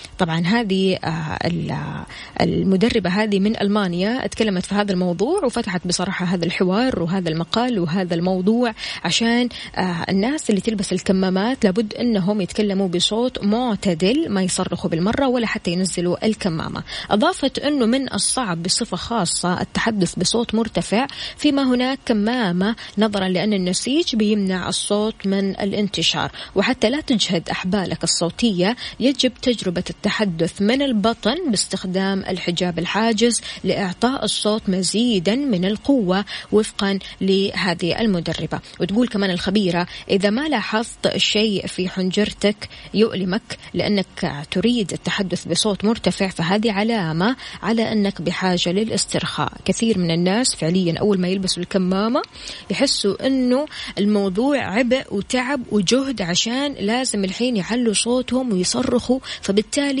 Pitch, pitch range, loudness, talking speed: 205 Hz, 185-230 Hz, -20 LUFS, 115 wpm